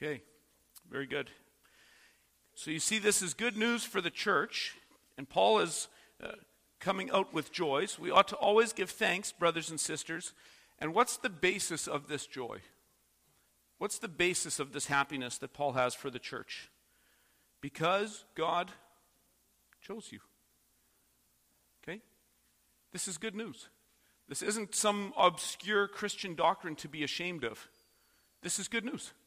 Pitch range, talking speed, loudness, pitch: 145-205 Hz, 150 wpm, -33 LUFS, 175 Hz